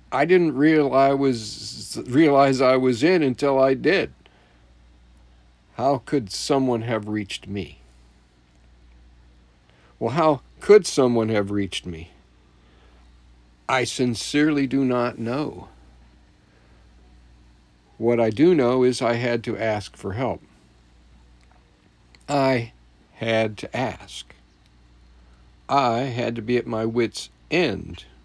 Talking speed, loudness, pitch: 115 wpm, -22 LUFS, 100 Hz